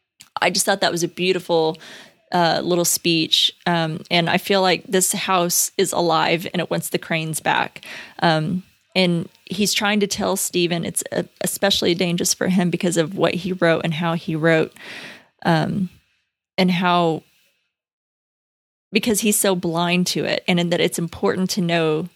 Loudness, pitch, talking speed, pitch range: -20 LUFS, 175 Hz, 170 wpm, 170-185 Hz